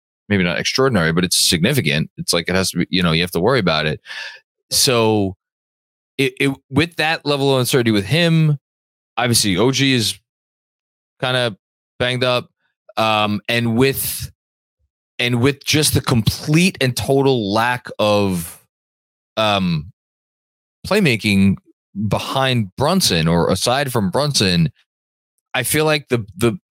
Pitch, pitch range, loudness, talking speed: 115 Hz, 90-135 Hz, -17 LUFS, 140 wpm